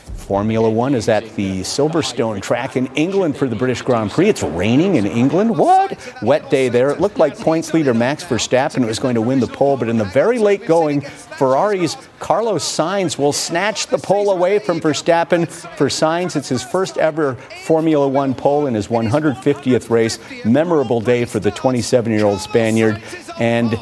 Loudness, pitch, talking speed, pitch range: -17 LUFS, 135 Hz, 180 wpm, 115-165 Hz